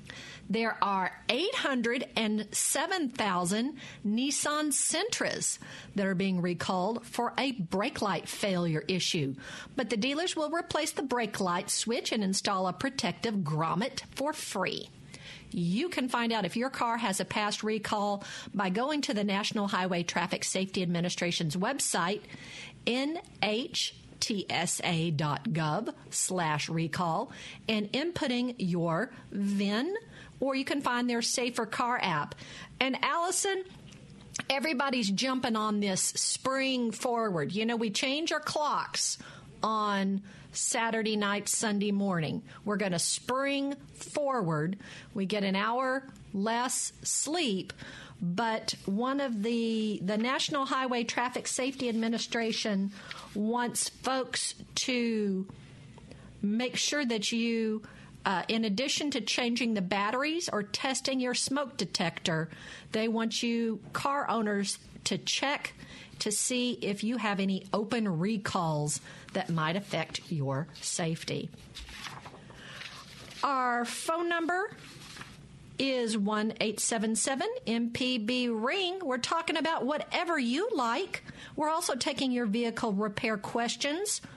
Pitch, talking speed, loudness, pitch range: 225 Hz, 120 wpm, -31 LUFS, 195-260 Hz